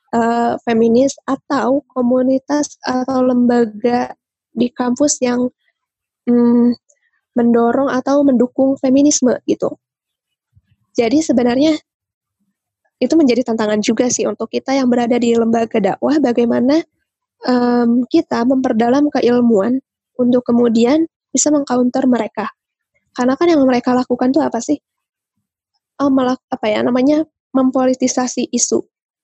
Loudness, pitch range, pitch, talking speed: -15 LUFS, 240-270 Hz, 250 Hz, 110 wpm